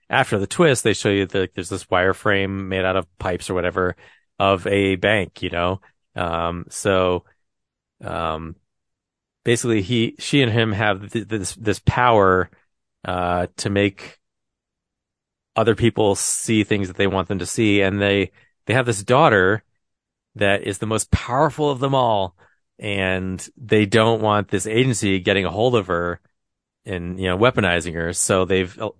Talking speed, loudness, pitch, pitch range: 165 wpm, -20 LUFS, 100 Hz, 90-110 Hz